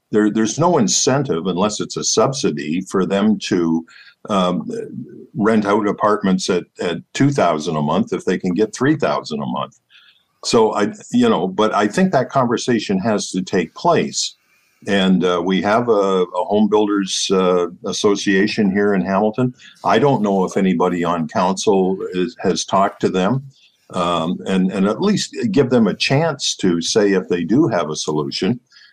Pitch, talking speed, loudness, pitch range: 100 Hz, 170 wpm, -18 LUFS, 95-110 Hz